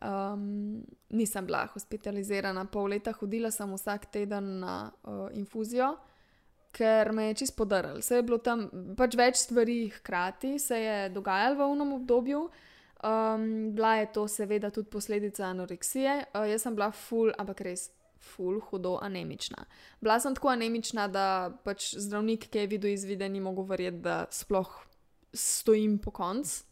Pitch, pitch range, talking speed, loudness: 210 Hz, 195-230 Hz, 155 wpm, -31 LUFS